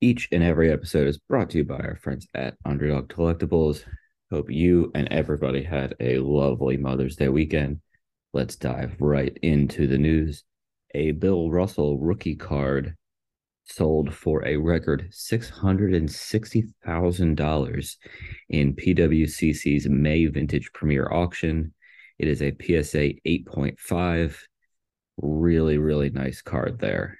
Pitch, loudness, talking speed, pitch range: 75 Hz, -24 LUFS, 125 wpm, 70-85 Hz